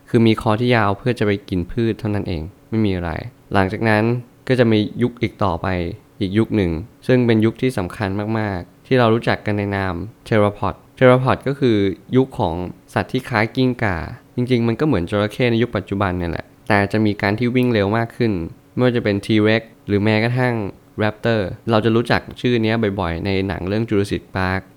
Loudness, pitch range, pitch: -19 LUFS, 100-120 Hz, 110 Hz